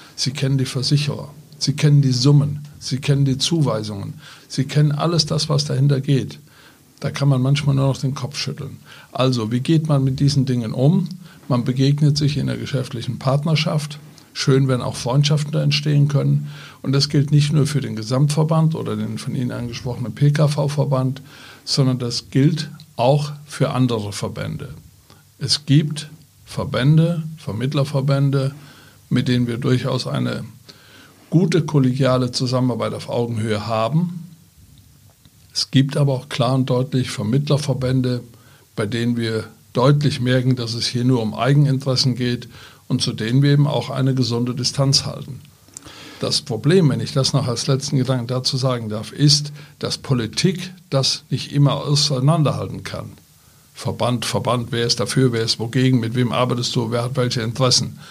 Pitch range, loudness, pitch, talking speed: 125-145 Hz, -19 LUFS, 135 Hz, 155 wpm